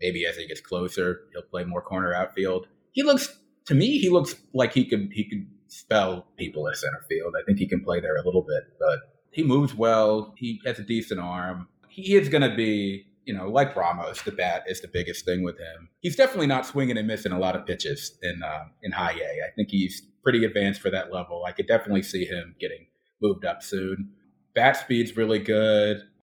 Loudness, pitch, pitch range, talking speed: -26 LUFS, 110 Hz, 95-155 Hz, 220 wpm